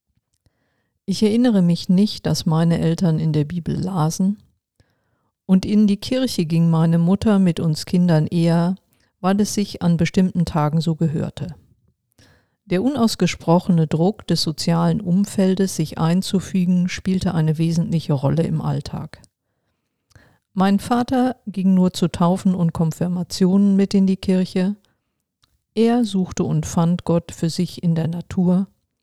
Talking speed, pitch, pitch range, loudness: 135 wpm, 180 Hz, 165-195 Hz, -19 LUFS